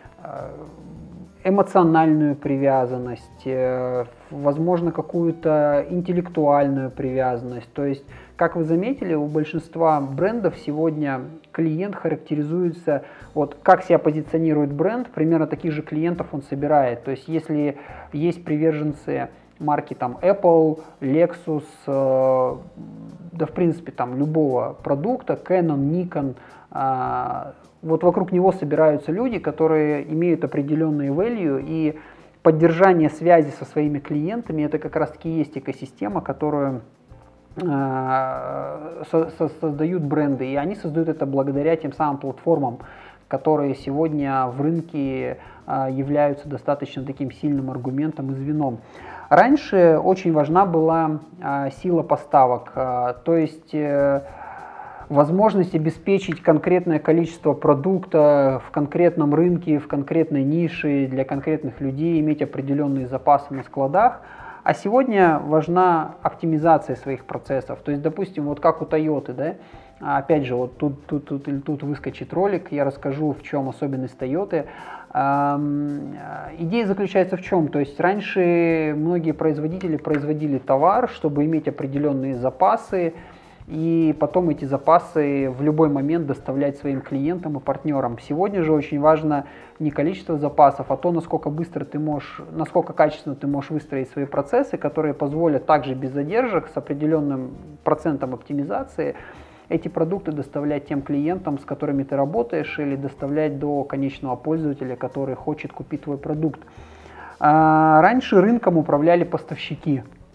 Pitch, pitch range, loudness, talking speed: 150 Hz, 140-165 Hz, -21 LUFS, 125 wpm